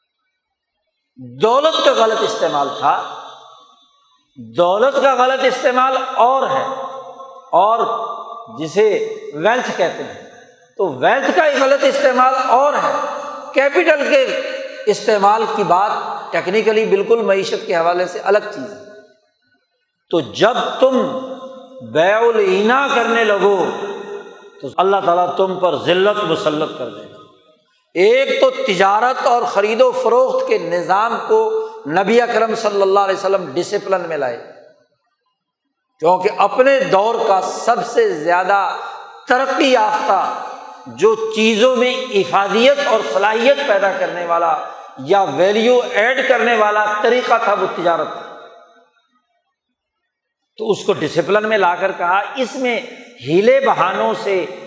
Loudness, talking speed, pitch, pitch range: -15 LUFS, 125 wpm, 250 Hz, 200-290 Hz